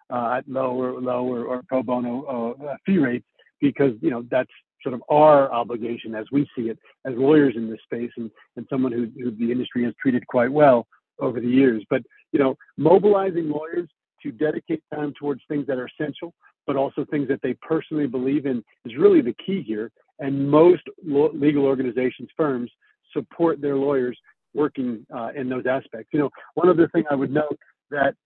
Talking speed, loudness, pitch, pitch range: 195 wpm, -22 LUFS, 135 Hz, 125-150 Hz